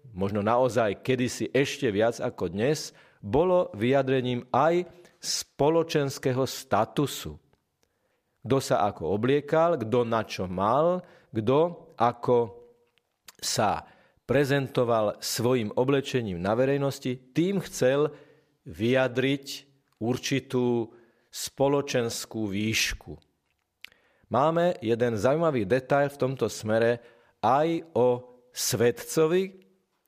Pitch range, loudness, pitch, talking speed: 115-140 Hz, -26 LUFS, 130 Hz, 90 wpm